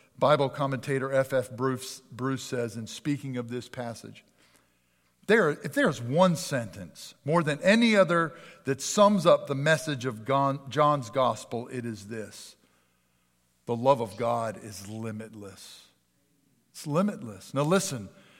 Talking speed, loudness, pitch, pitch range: 145 wpm, -27 LUFS, 130 Hz, 110-145 Hz